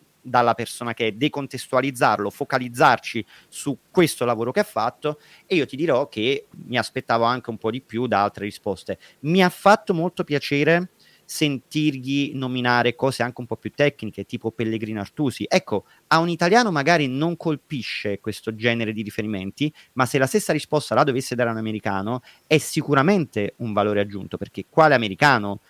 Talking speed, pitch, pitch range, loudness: 170 wpm, 130 Hz, 110-150 Hz, -22 LUFS